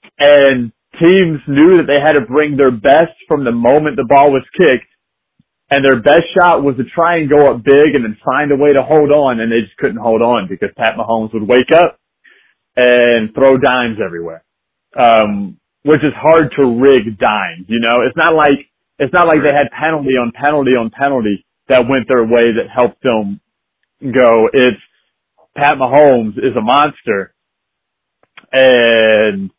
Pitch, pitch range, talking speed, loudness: 135 Hz, 115-145 Hz, 180 wpm, -11 LUFS